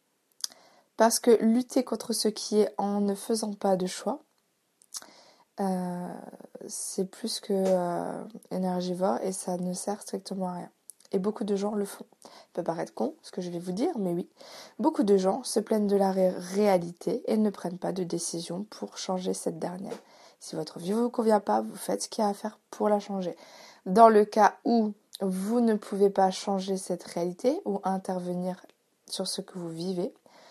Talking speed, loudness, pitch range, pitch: 195 wpm, -28 LUFS, 185-220 Hz, 200 Hz